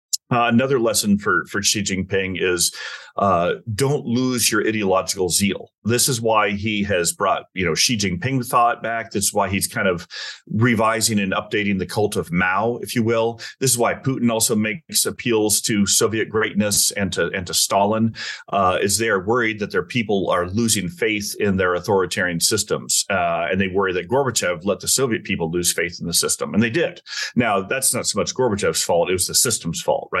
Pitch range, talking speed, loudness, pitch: 100-115 Hz, 205 wpm, -19 LUFS, 110 Hz